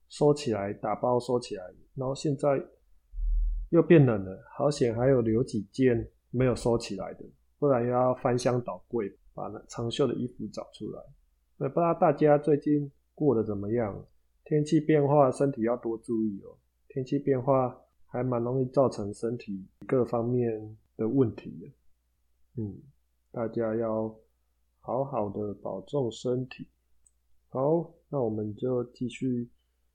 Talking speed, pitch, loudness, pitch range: 215 characters per minute, 120 Hz, -28 LUFS, 100-135 Hz